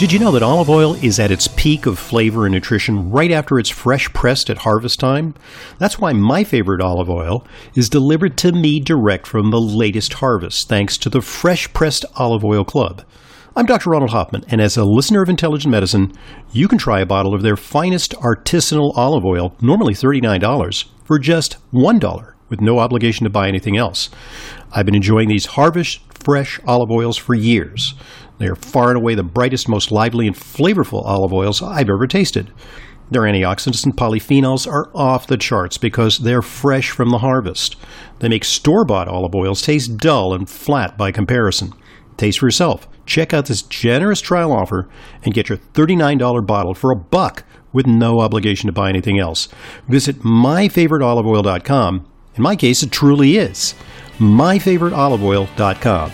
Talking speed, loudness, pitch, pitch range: 175 wpm, -15 LUFS, 120 Hz, 105-140 Hz